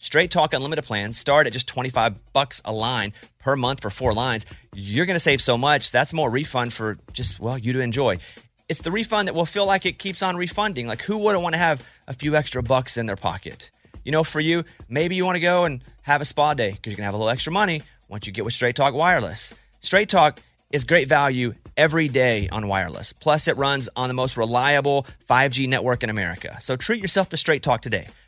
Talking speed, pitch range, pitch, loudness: 240 wpm, 115-160 Hz, 135 Hz, -21 LUFS